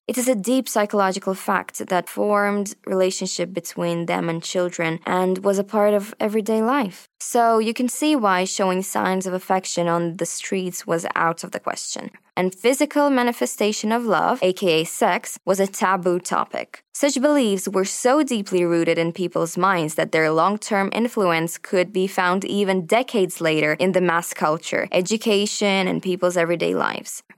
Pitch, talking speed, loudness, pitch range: 190 Hz, 165 wpm, -21 LUFS, 175-220 Hz